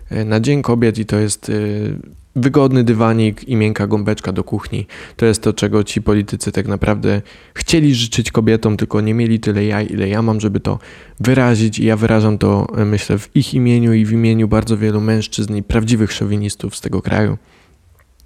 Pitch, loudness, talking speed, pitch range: 110 Hz, -16 LUFS, 180 wpm, 105-115 Hz